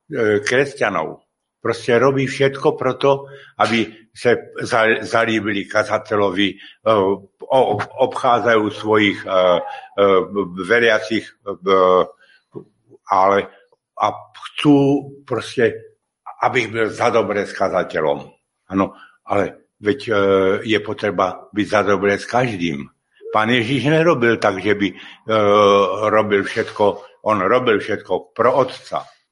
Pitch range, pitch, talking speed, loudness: 100-120 Hz, 105 Hz, 100 wpm, -18 LUFS